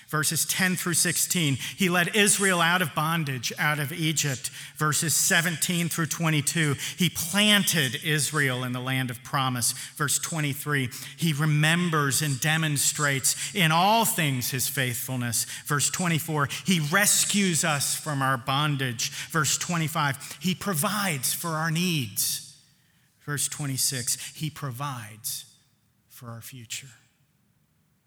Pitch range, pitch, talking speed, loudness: 135-165 Hz, 150 Hz, 125 wpm, -24 LUFS